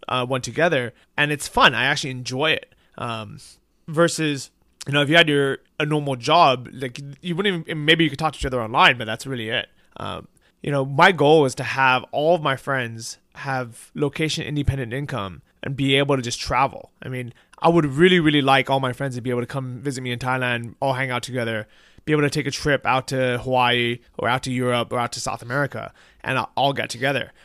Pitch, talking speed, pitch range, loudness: 135 Hz, 225 wpm, 125-150 Hz, -21 LUFS